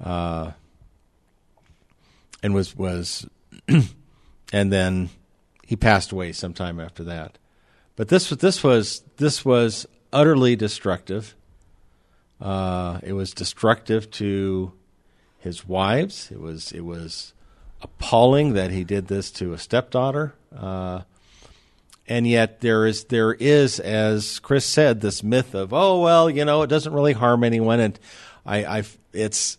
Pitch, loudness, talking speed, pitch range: 105 Hz, -21 LUFS, 130 wpm, 95-125 Hz